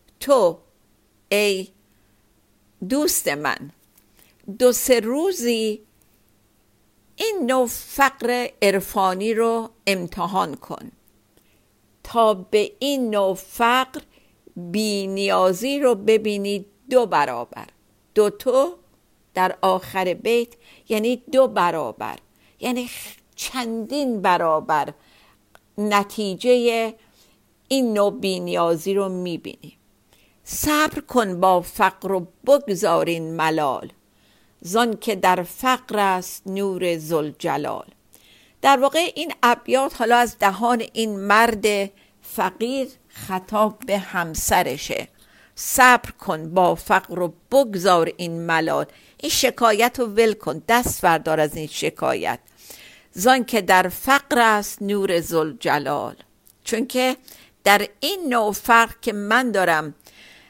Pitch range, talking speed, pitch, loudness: 180-245 Hz, 105 wpm, 205 Hz, -20 LUFS